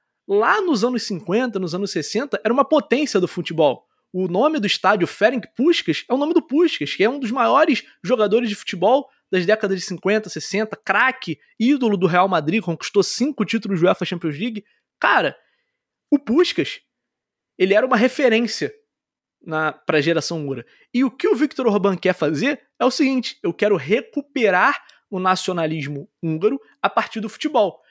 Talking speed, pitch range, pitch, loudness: 170 wpm, 185-265 Hz, 215 Hz, -20 LUFS